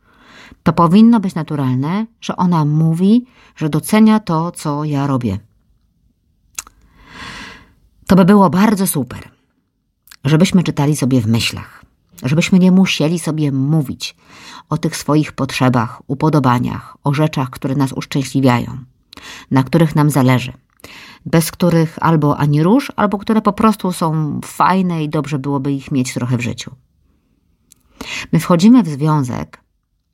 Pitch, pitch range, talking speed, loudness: 150 Hz, 130-180 Hz, 130 wpm, -15 LUFS